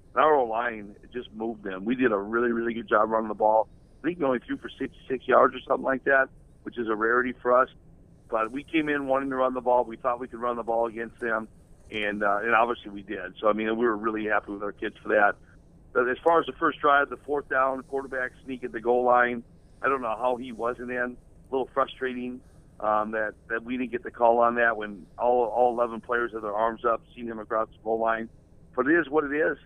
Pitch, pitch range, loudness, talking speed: 120 Hz, 110-125 Hz, -26 LUFS, 255 wpm